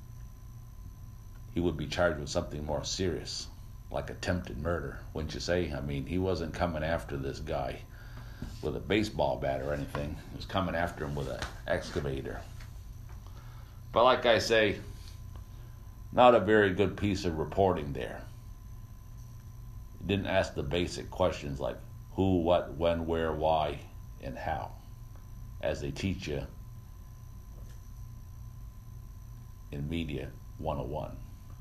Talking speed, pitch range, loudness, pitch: 130 wpm, 85-110 Hz, -31 LUFS, 100 Hz